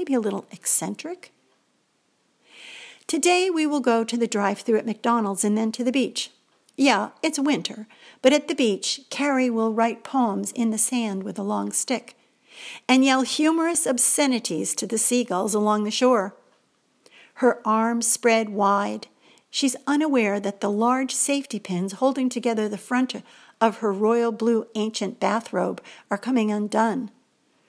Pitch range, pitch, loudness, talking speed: 215-260 Hz, 235 Hz, -23 LUFS, 155 wpm